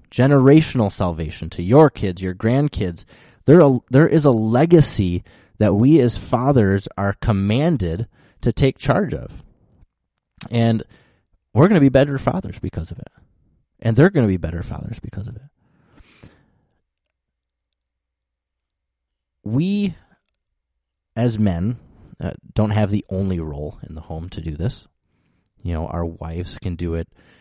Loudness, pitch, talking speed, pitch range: -18 LUFS, 100 Hz, 140 wpm, 85-125 Hz